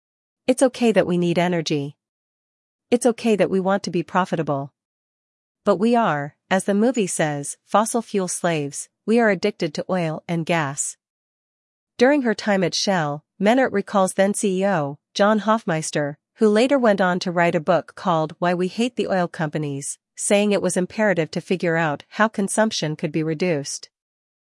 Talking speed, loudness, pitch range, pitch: 170 wpm, -21 LUFS, 160-210 Hz, 180 Hz